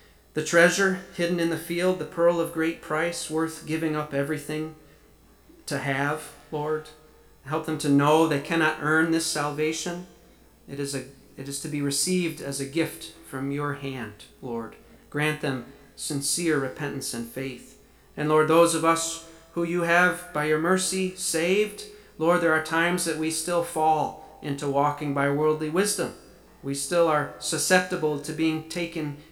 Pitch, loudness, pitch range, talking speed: 155 Hz, -25 LUFS, 145-170 Hz, 165 wpm